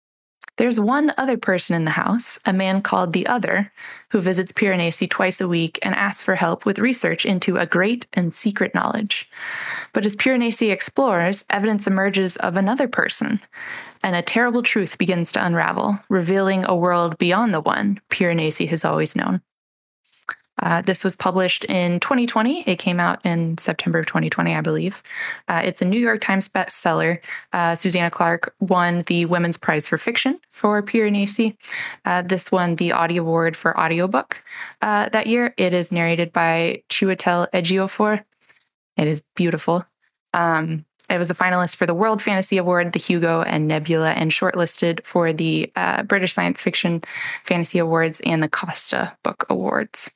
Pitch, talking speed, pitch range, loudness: 185 Hz, 165 wpm, 170-210 Hz, -19 LUFS